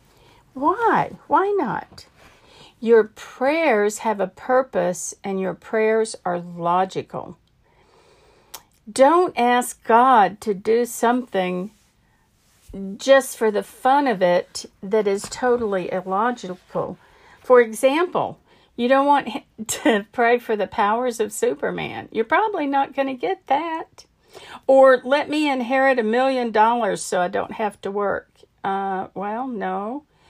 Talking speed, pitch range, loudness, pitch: 125 wpm, 205-270 Hz, -20 LUFS, 235 Hz